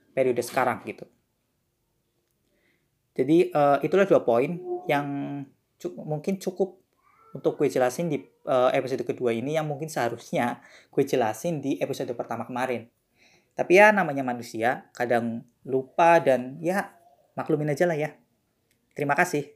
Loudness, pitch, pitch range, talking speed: -25 LUFS, 145 Hz, 125-175 Hz, 130 wpm